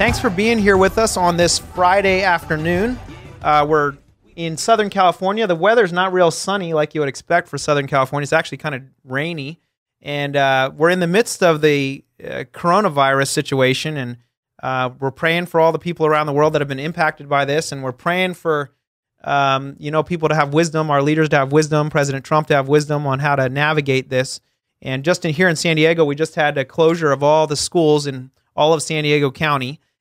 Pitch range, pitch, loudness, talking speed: 140-170 Hz, 150 Hz, -17 LUFS, 215 wpm